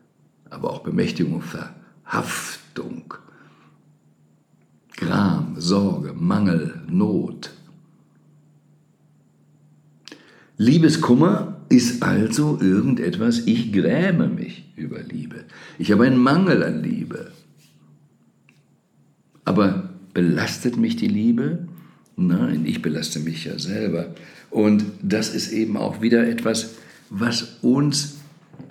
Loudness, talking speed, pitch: -21 LUFS, 90 wpm, 130 Hz